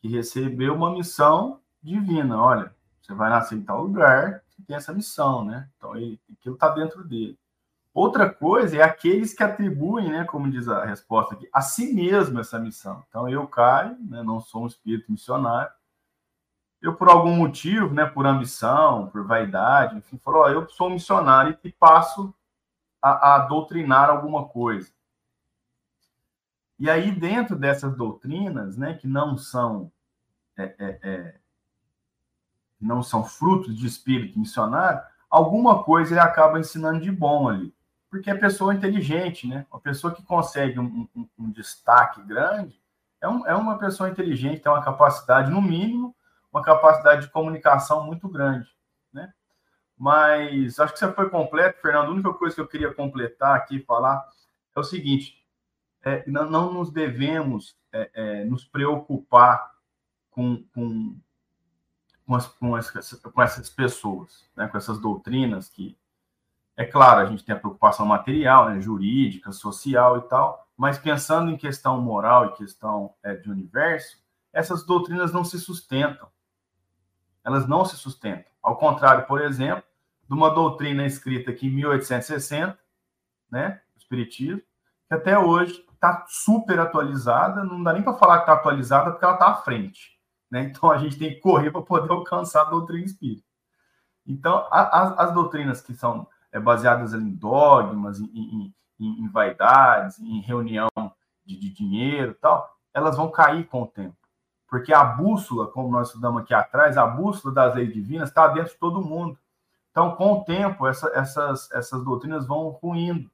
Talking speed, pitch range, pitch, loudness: 160 wpm, 120-170 Hz, 145 Hz, -21 LUFS